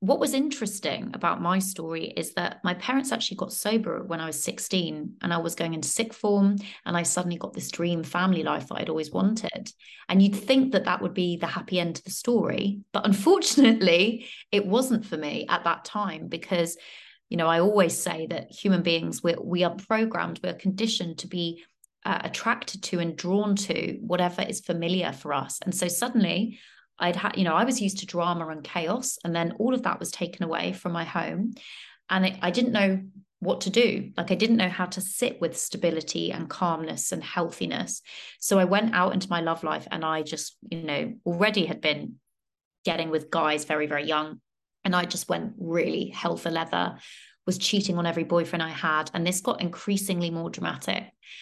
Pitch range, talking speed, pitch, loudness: 170-210 Hz, 205 wpm, 180 Hz, -26 LUFS